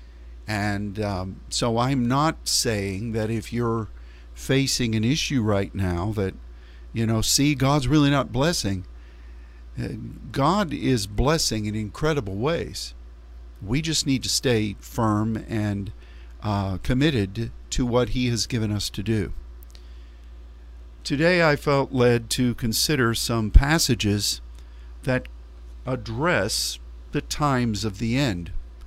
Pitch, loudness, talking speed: 105 Hz, -24 LUFS, 125 wpm